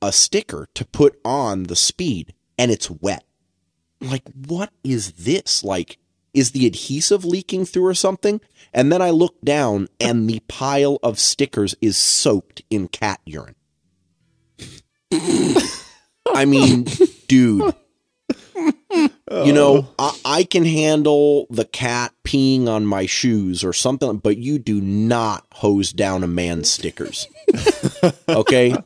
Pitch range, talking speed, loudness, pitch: 100-150 Hz, 135 wpm, -18 LUFS, 125 Hz